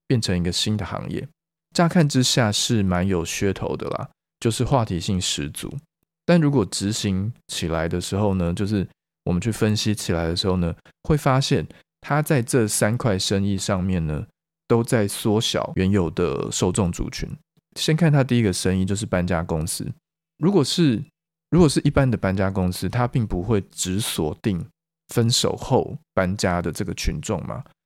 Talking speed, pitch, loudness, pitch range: 255 characters per minute, 110 Hz, -22 LUFS, 95-145 Hz